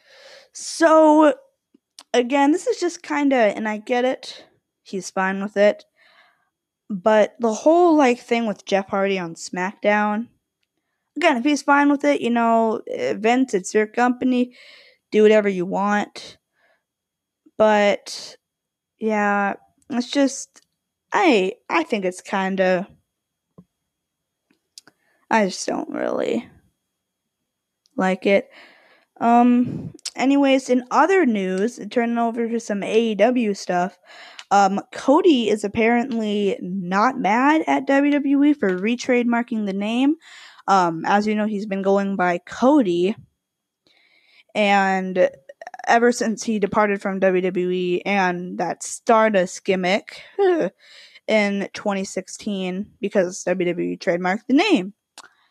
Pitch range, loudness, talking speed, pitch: 195-265 Hz, -20 LUFS, 115 wpm, 220 Hz